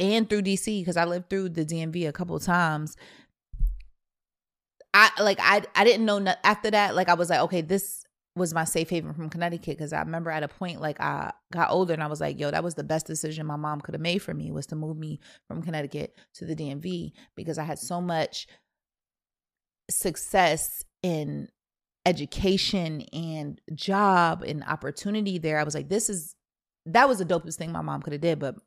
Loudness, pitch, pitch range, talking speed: -26 LUFS, 165 Hz, 150-185 Hz, 205 wpm